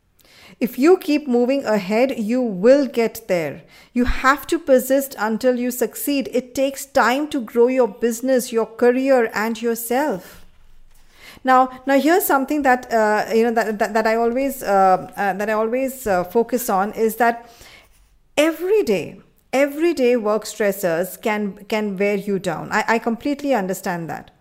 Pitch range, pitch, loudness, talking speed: 215-265 Hz, 235 Hz, -19 LUFS, 165 wpm